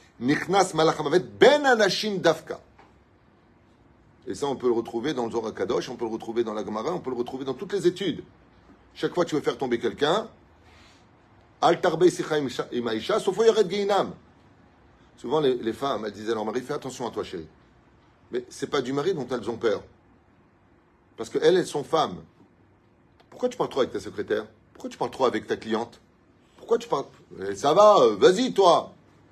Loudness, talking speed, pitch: -25 LUFS, 185 wpm, 160 Hz